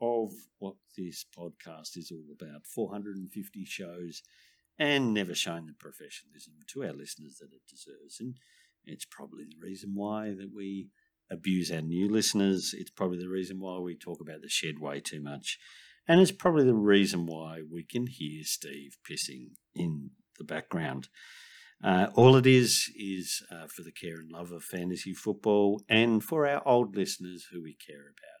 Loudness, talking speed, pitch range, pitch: -29 LUFS, 175 wpm, 85-105 Hz, 95 Hz